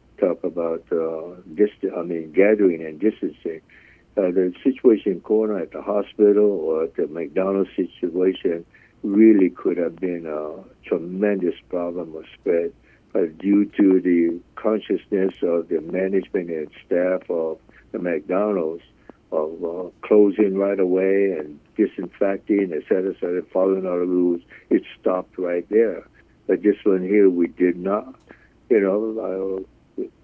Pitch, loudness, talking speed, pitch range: 95 Hz, -22 LUFS, 145 wpm, 85-100 Hz